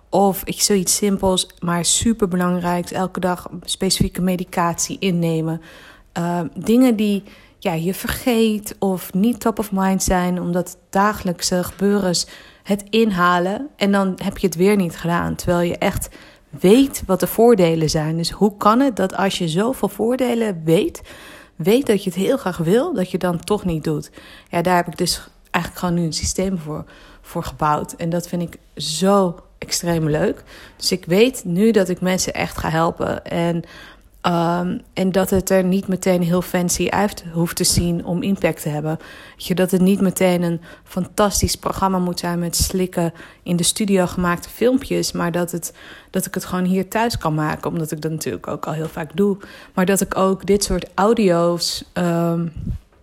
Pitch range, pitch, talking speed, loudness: 170-200 Hz, 185 Hz, 180 wpm, -19 LUFS